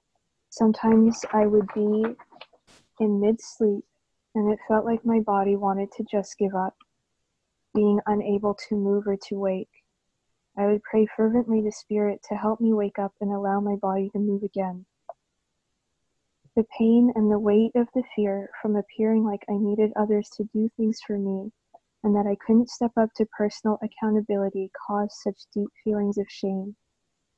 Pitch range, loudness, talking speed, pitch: 200-220 Hz, -25 LUFS, 170 wpm, 210 Hz